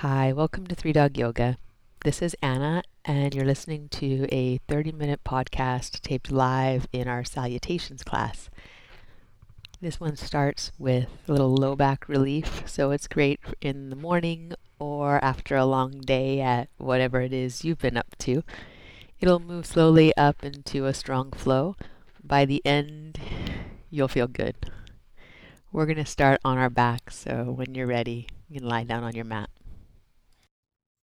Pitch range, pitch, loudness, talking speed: 120-145 Hz, 135 Hz, -26 LUFS, 160 wpm